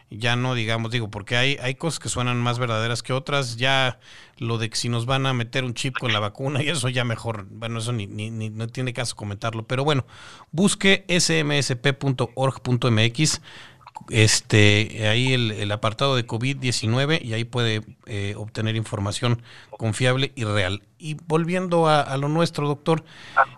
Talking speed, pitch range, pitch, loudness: 175 wpm, 110-135 Hz, 125 Hz, -23 LUFS